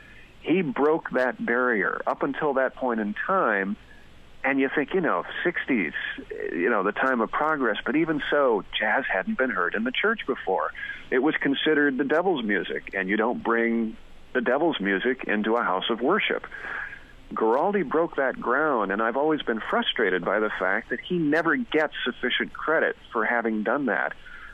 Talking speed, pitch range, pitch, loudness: 180 wpm, 115-155 Hz, 135 Hz, -25 LUFS